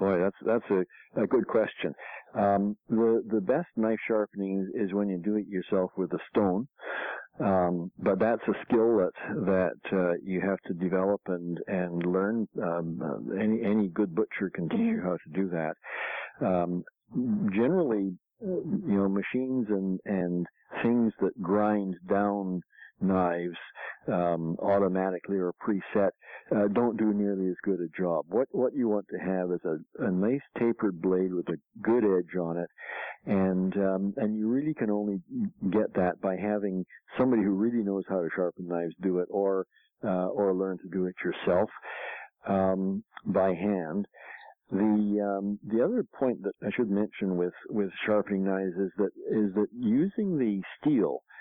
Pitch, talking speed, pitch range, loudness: 100 Hz, 165 wpm, 90-105 Hz, -29 LUFS